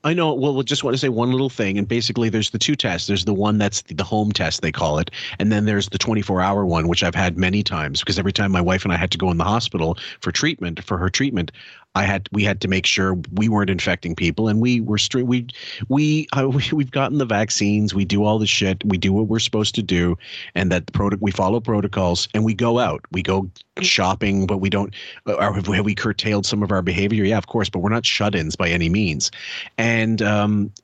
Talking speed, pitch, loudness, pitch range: 255 wpm, 105 Hz, -20 LUFS, 95-115 Hz